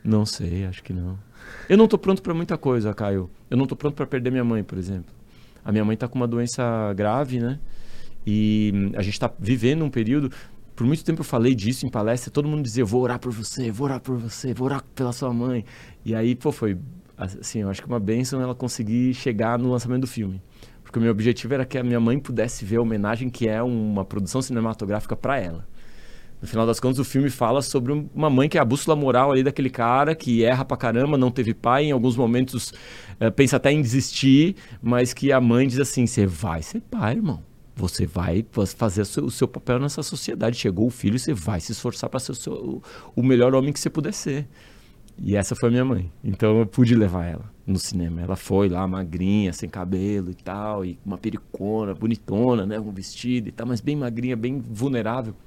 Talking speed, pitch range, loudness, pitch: 220 wpm, 105-130 Hz, -23 LUFS, 120 Hz